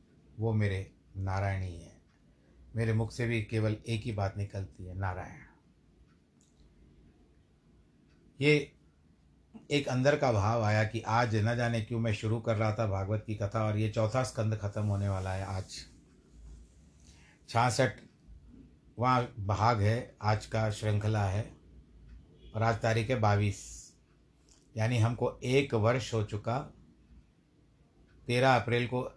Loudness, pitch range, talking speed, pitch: -31 LUFS, 90-115 Hz, 135 wpm, 105 Hz